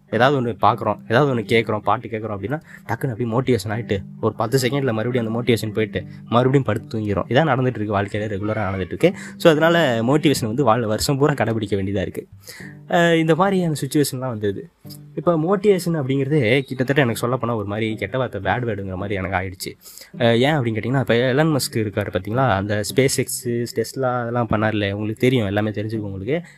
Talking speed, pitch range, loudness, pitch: 180 wpm, 105-140 Hz, -20 LUFS, 120 Hz